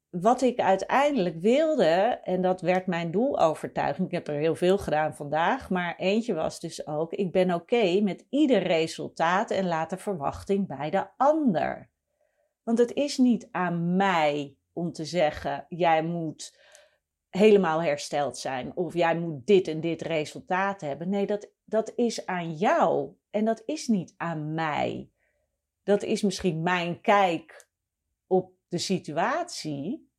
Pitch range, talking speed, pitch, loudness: 160-210 Hz, 155 wpm, 185 Hz, -26 LUFS